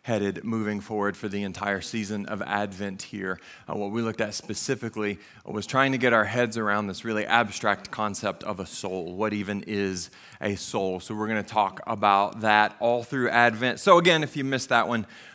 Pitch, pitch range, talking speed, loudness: 105 Hz, 100-115 Hz, 200 wpm, -26 LUFS